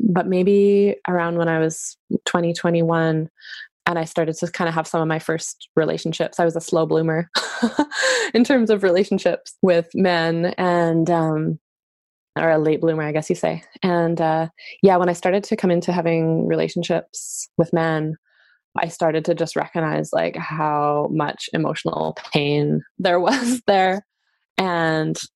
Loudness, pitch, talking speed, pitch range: -20 LUFS, 170 Hz, 160 wpm, 160-185 Hz